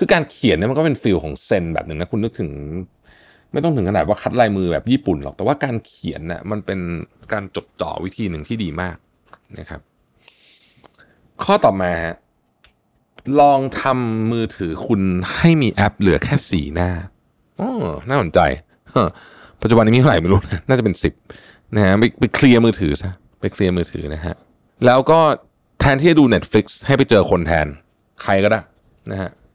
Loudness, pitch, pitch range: -17 LUFS, 100 Hz, 85-120 Hz